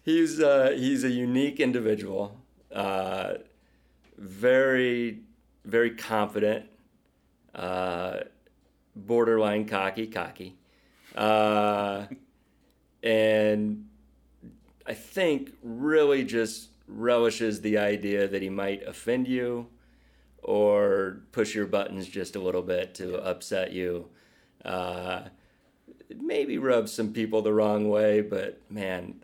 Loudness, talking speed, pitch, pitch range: -27 LUFS, 100 wpm, 110 Hz, 100-120 Hz